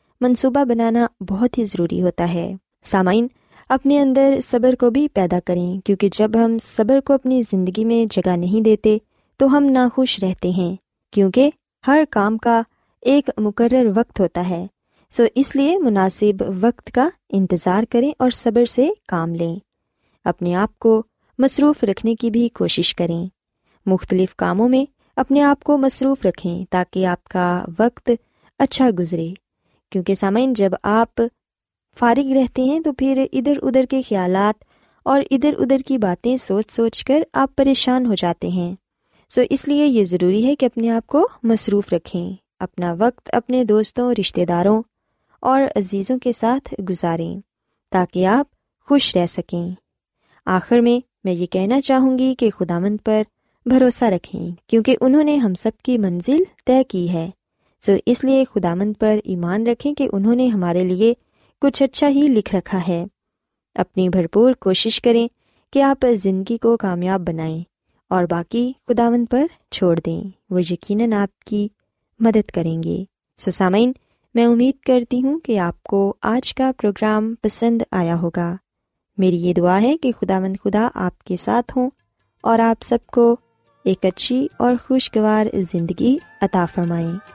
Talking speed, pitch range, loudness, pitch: 160 wpm, 185-255 Hz, -18 LUFS, 225 Hz